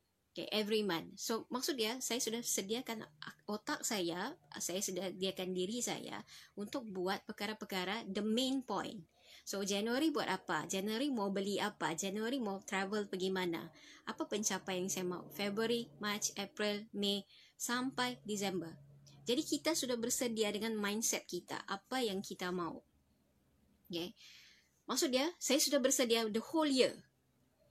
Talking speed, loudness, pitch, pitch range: 145 wpm, -38 LUFS, 205 Hz, 185-235 Hz